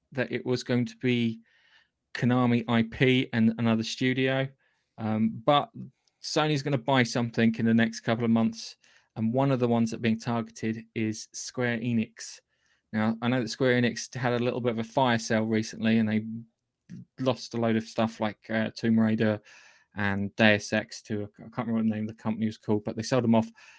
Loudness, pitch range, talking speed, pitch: -27 LUFS, 110-125 Hz, 205 wpm, 115 Hz